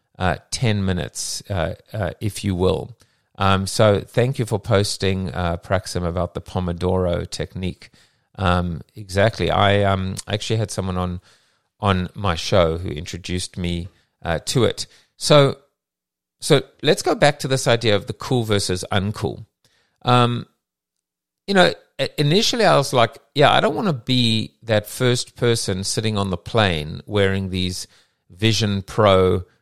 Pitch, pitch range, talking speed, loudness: 100 Hz, 90-115 Hz, 150 wpm, -20 LUFS